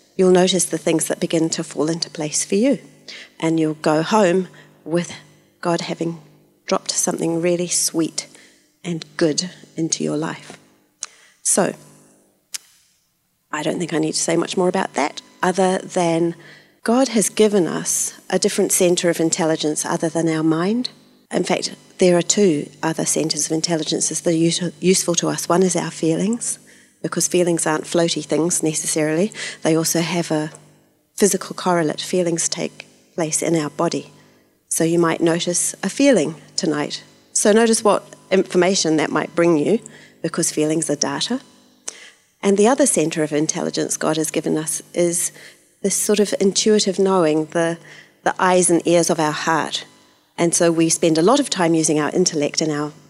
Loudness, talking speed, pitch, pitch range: -19 LUFS, 165 wpm, 170 Hz, 160-185 Hz